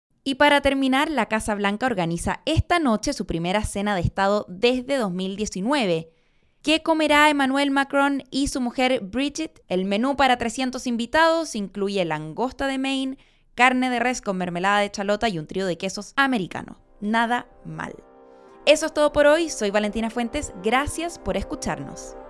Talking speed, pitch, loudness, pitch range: 160 wpm, 240 Hz, -22 LUFS, 200-275 Hz